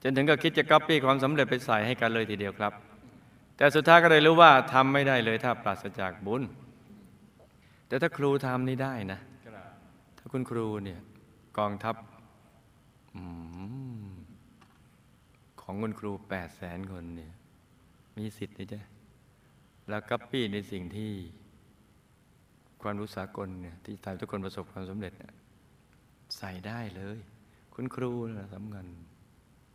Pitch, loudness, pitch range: 105 Hz, -27 LUFS, 95-125 Hz